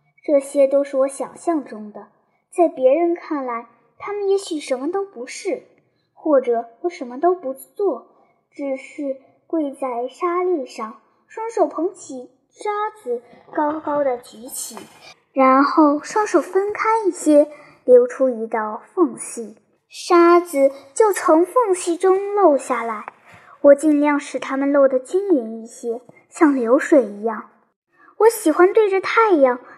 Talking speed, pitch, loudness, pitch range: 195 characters per minute, 290 Hz, -19 LUFS, 260-360 Hz